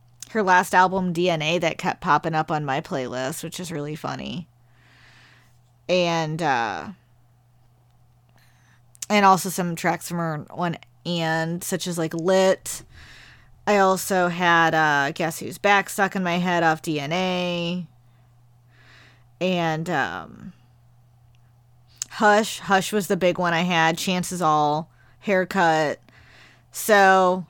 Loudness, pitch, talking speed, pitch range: -22 LUFS, 165 Hz, 125 wpm, 120-180 Hz